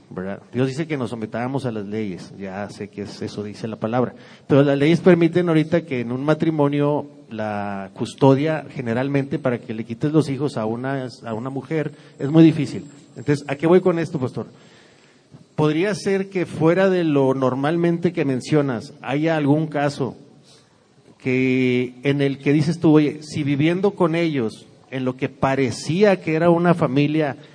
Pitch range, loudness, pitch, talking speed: 125-155 Hz, -20 LUFS, 140 Hz, 175 wpm